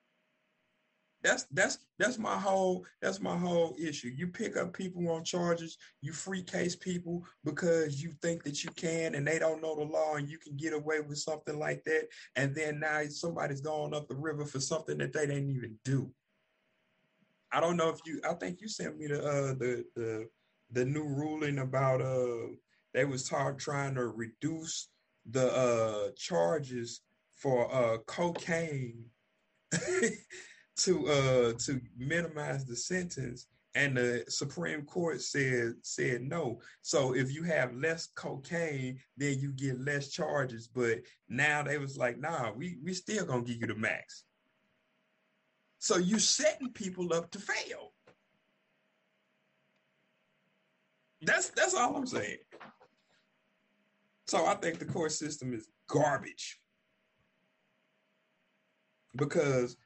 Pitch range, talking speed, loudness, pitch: 130-165 Hz, 145 wpm, -34 LUFS, 150 Hz